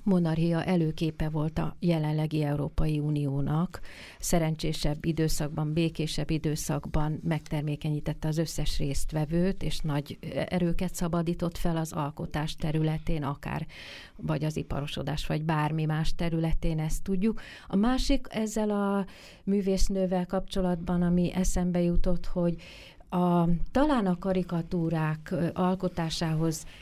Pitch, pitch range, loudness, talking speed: 165 Hz, 155-180 Hz, -30 LUFS, 105 wpm